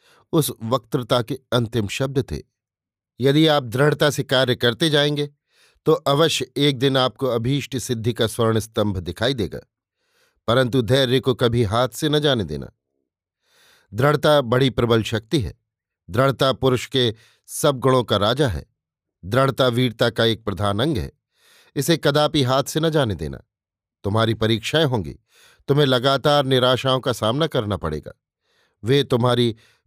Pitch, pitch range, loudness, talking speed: 130 Hz, 115-140 Hz, -20 LUFS, 145 wpm